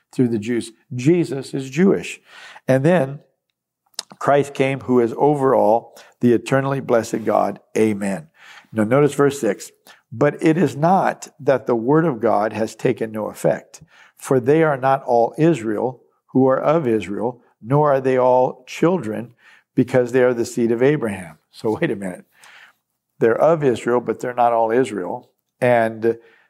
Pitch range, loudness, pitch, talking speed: 115-140 Hz, -19 LUFS, 125 Hz, 160 wpm